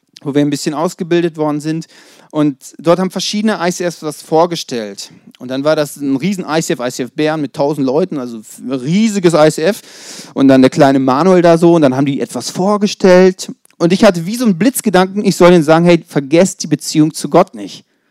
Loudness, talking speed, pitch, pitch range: -12 LUFS, 200 wpm, 165 Hz, 145-185 Hz